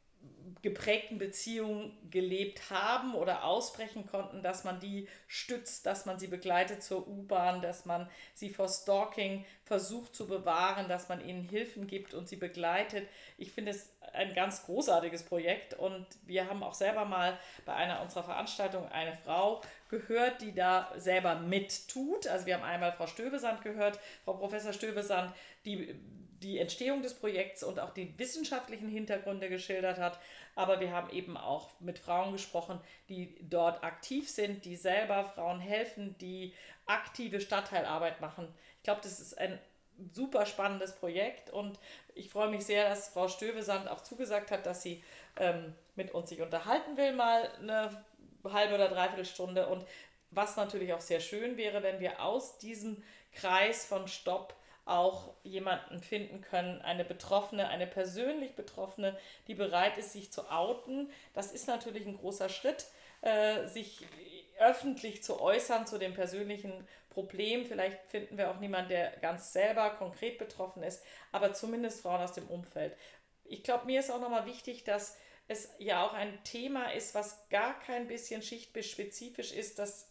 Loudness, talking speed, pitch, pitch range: -36 LUFS, 160 wpm, 200 Hz, 185-215 Hz